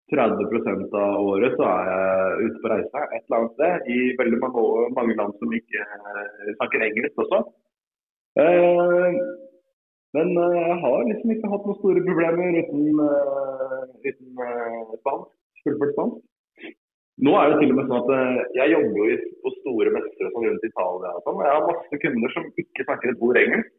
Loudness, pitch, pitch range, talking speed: -22 LUFS, 150 Hz, 120-185 Hz, 160 wpm